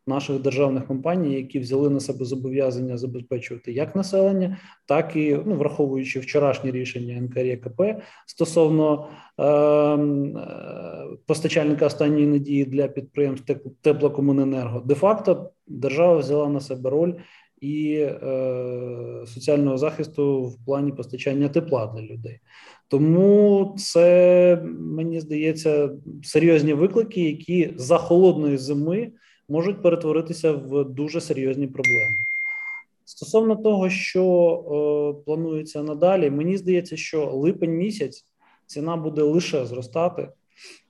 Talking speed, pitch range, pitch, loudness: 110 wpm, 135-170 Hz, 150 Hz, -22 LUFS